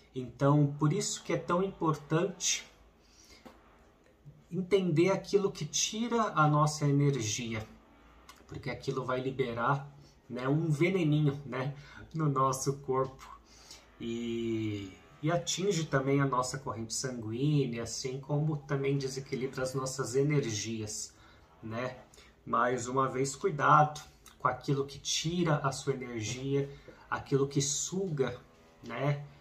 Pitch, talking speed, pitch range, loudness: 135 Hz, 115 wpm, 125-150 Hz, -32 LUFS